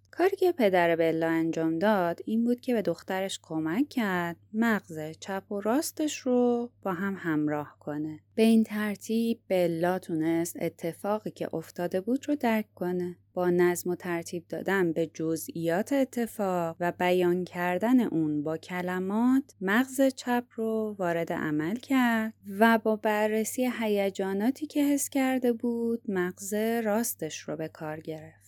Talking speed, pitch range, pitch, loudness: 145 wpm, 170-230 Hz, 195 Hz, -28 LUFS